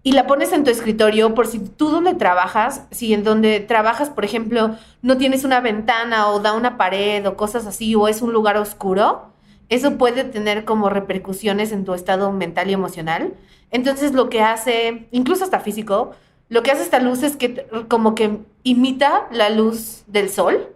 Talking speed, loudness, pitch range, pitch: 190 wpm, -18 LUFS, 210-250 Hz, 220 Hz